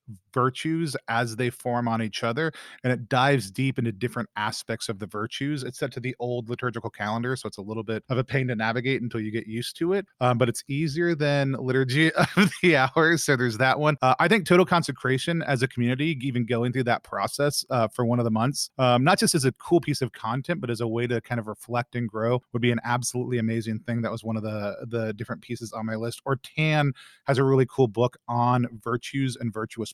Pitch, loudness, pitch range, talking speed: 125 Hz, -25 LUFS, 115-140 Hz, 240 wpm